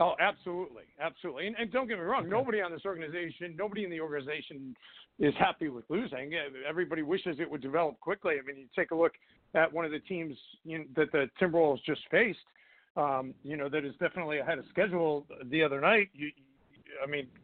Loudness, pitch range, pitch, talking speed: -32 LUFS, 145-180 Hz, 160 Hz, 210 wpm